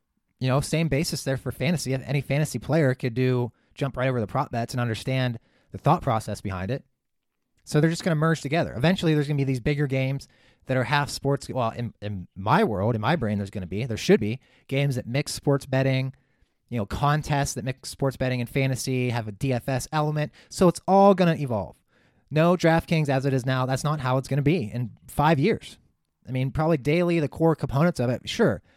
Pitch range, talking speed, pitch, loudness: 125-150 Hz, 225 wpm, 135 Hz, -25 LUFS